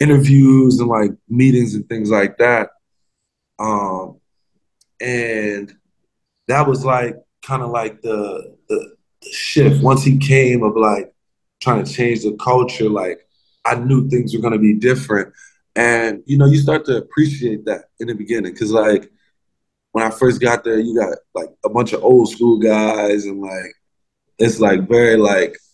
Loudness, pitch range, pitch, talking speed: -16 LUFS, 110-135 Hz, 120 Hz, 170 wpm